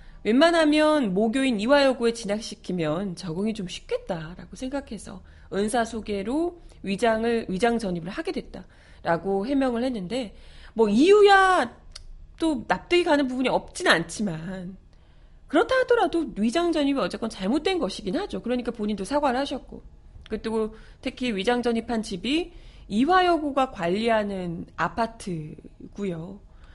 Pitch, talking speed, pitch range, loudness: 230 Hz, 305 characters per minute, 195-285 Hz, -24 LUFS